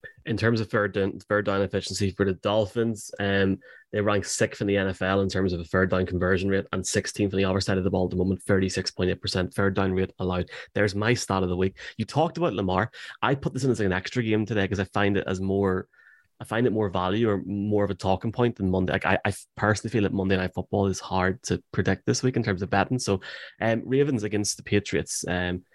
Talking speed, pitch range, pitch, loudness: 255 wpm, 95-110 Hz, 100 Hz, -26 LUFS